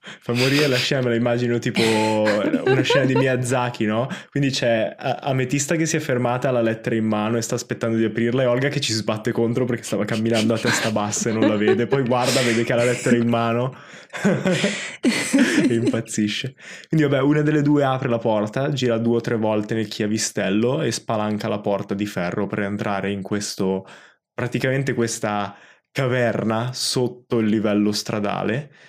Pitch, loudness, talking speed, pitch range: 120 Hz, -21 LUFS, 185 wpm, 110-130 Hz